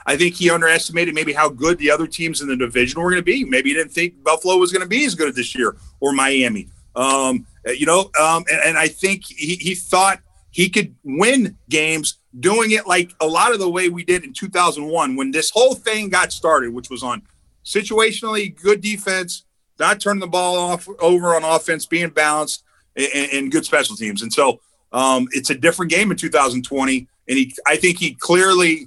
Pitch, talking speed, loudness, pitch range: 170 Hz, 210 wpm, -17 LUFS, 150-190 Hz